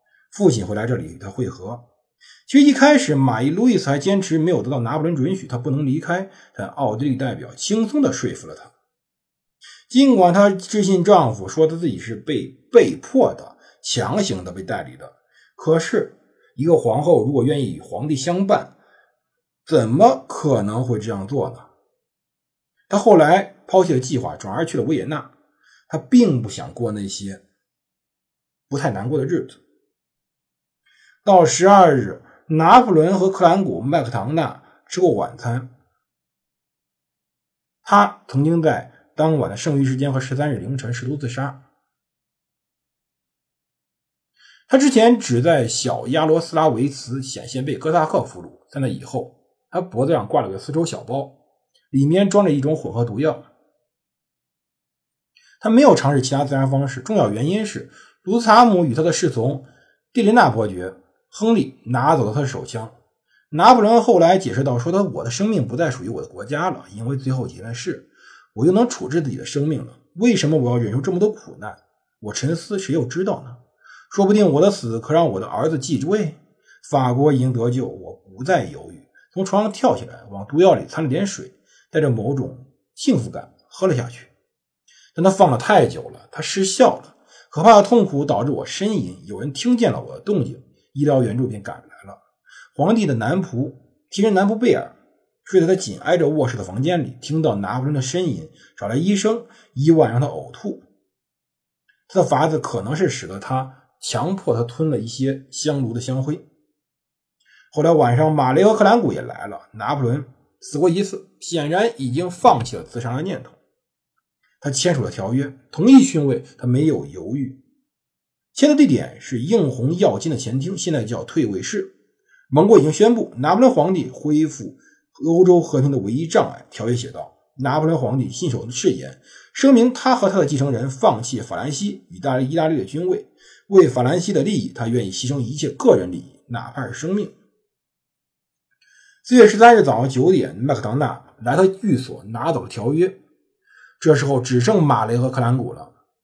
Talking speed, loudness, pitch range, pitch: 265 characters per minute, -18 LUFS, 130-195 Hz, 150 Hz